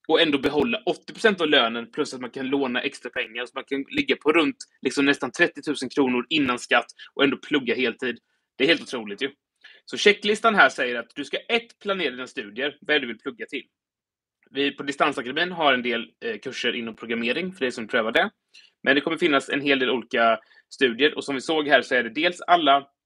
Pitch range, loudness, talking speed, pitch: 125-155 Hz, -23 LUFS, 225 wpm, 140 Hz